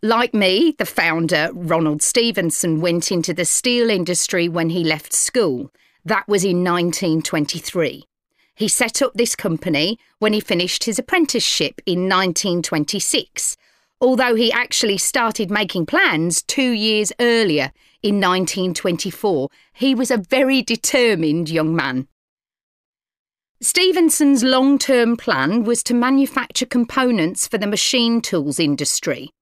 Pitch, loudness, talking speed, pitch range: 210 Hz, -18 LUFS, 125 wpm, 175-245 Hz